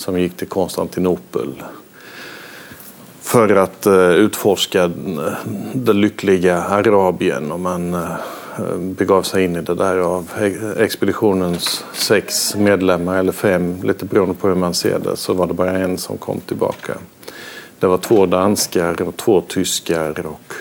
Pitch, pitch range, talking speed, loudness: 90 Hz, 90-95 Hz, 135 wpm, -17 LUFS